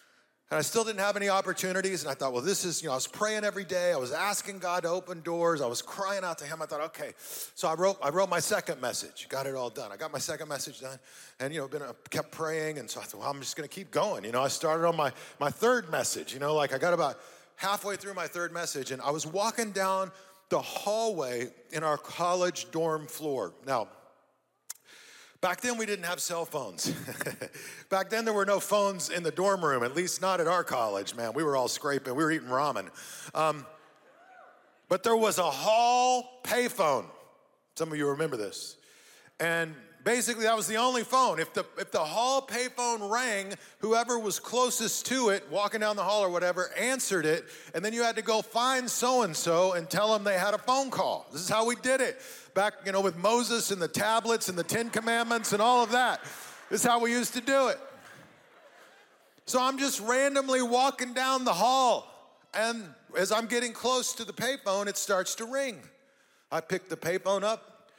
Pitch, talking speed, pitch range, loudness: 200 Hz, 215 wpm, 165-235 Hz, -29 LUFS